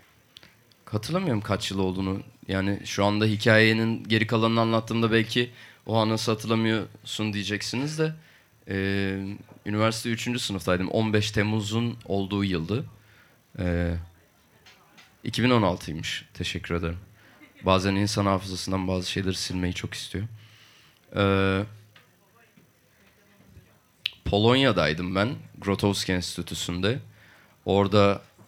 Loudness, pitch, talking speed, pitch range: -26 LUFS, 105 Hz, 95 wpm, 95-115 Hz